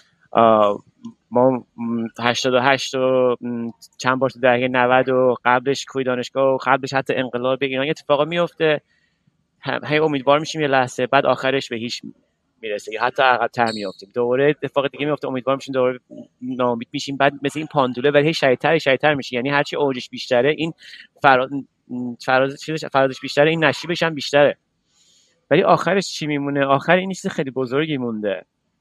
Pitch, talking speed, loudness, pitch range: 135 Hz, 160 wpm, -19 LUFS, 125-150 Hz